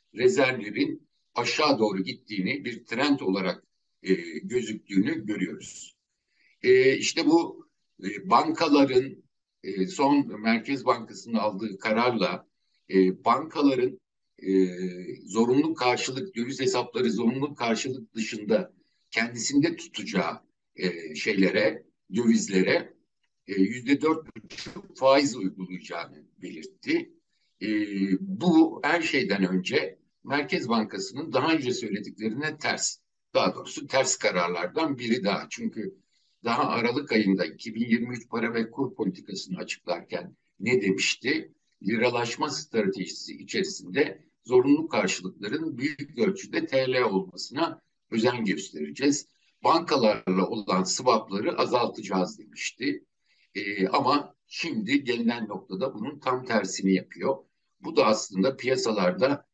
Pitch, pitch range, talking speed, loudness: 125 Hz, 105-155 Hz, 100 wpm, -27 LUFS